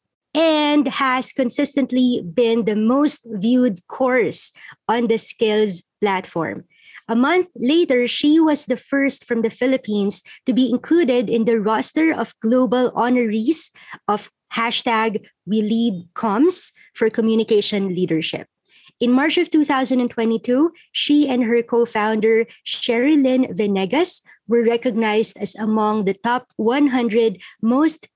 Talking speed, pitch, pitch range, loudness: 120 wpm, 240 Hz, 220-270 Hz, -19 LUFS